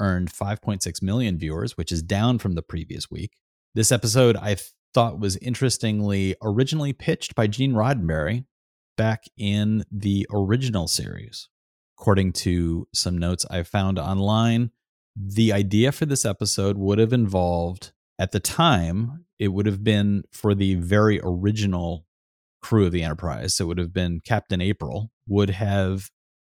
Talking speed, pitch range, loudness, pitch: 150 wpm, 90-110 Hz, -23 LUFS, 100 Hz